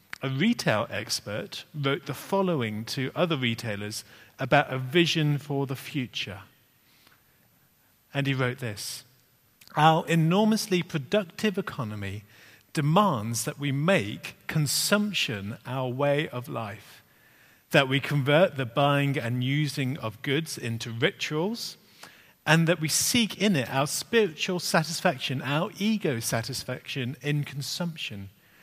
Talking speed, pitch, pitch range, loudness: 120 wpm, 140 Hz, 125-160 Hz, -27 LUFS